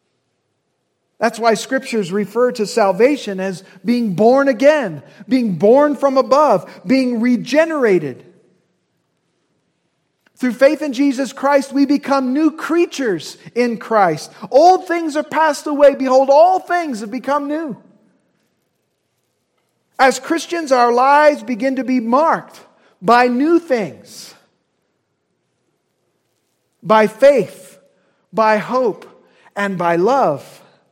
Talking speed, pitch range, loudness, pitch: 110 wpm, 220-290 Hz, -15 LUFS, 260 Hz